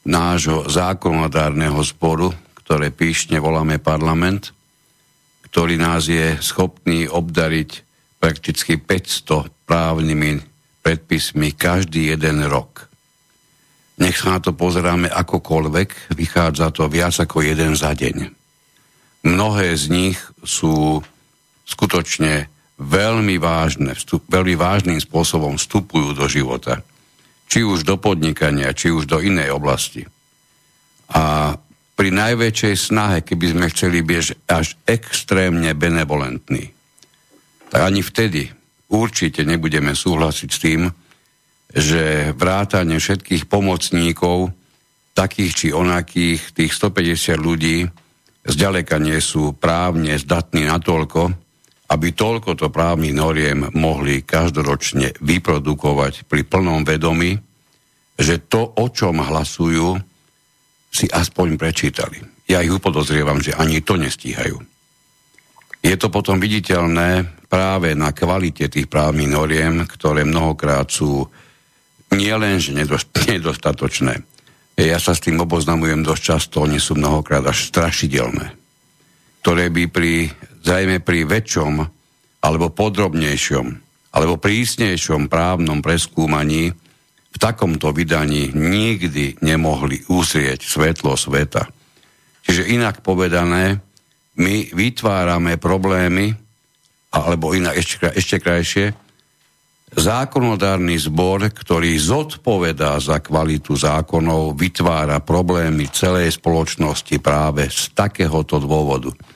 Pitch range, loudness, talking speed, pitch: 75-90 Hz, -17 LUFS, 105 wpm, 85 Hz